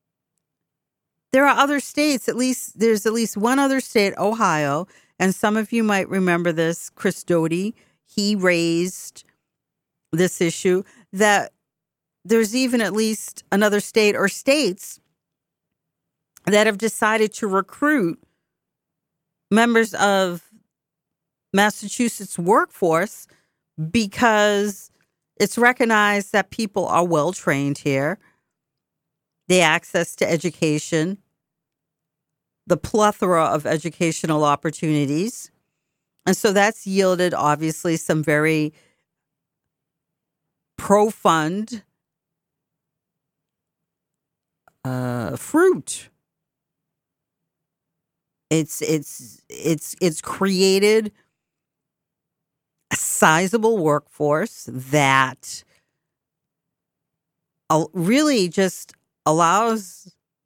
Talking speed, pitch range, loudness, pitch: 80 wpm, 160-210 Hz, -20 LUFS, 180 Hz